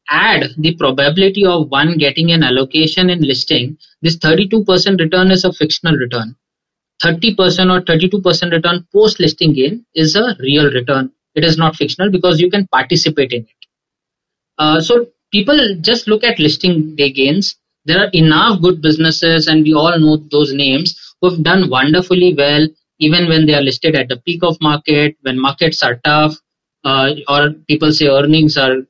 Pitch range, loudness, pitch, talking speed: 145-180 Hz, -12 LUFS, 160 Hz, 170 wpm